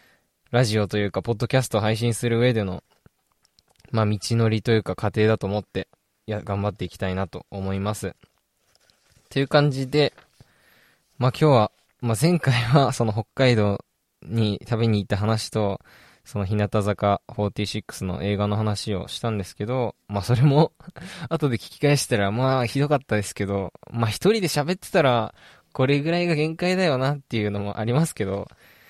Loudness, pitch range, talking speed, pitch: -23 LUFS, 105-130 Hz, 325 characters per minute, 110 Hz